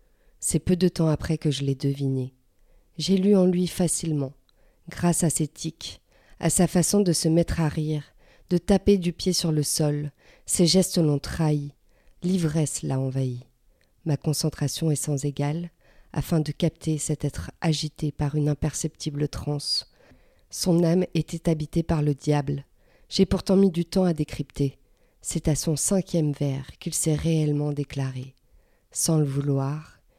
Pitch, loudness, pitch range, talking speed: 155 Hz, -25 LUFS, 145-170 Hz, 160 wpm